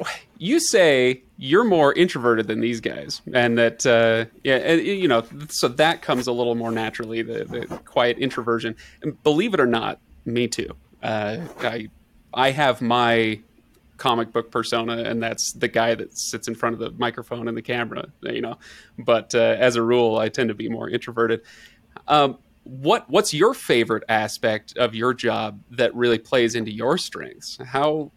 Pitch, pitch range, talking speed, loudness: 115 Hz, 115-125 Hz, 175 wpm, -22 LUFS